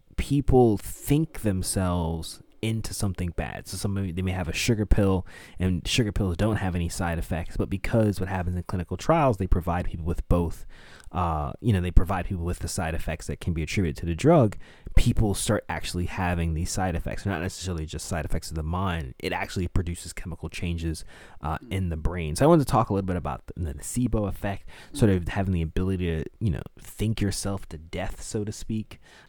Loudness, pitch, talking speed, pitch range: -27 LUFS, 90 Hz, 210 wpm, 85-100 Hz